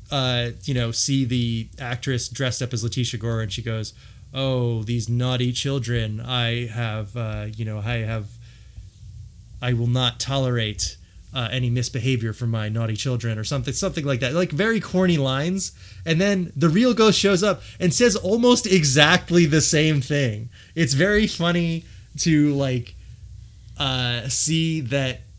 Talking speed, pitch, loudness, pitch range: 160 wpm, 125 Hz, -22 LUFS, 115-155 Hz